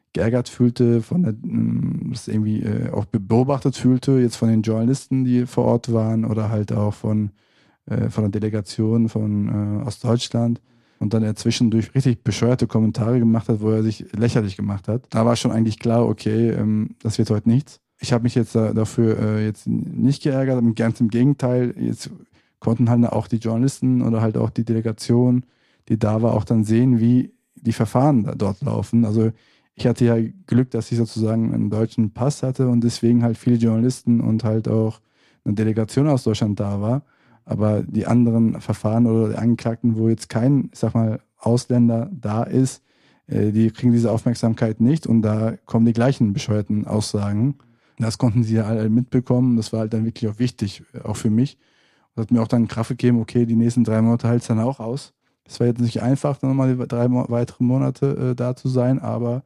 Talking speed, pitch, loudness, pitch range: 190 wpm, 115 Hz, -20 LUFS, 110-125 Hz